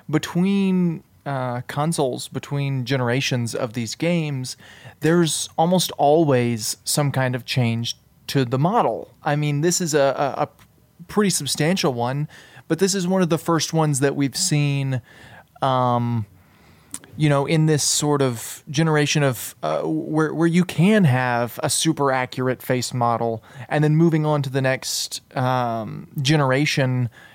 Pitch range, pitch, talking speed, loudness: 125-155 Hz, 140 Hz, 150 wpm, -21 LUFS